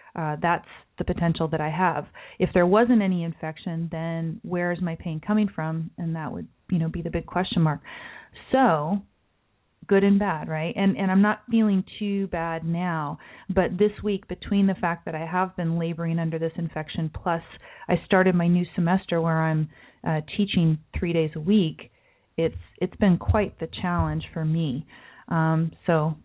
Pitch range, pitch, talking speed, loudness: 160-190 Hz, 170 Hz, 180 wpm, -25 LUFS